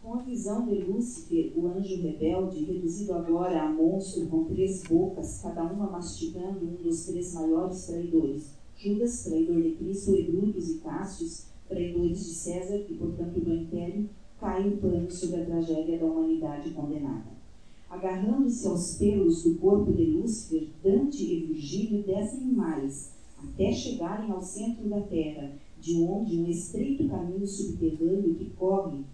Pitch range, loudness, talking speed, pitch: 165-200 Hz, -29 LUFS, 150 wpm, 180 Hz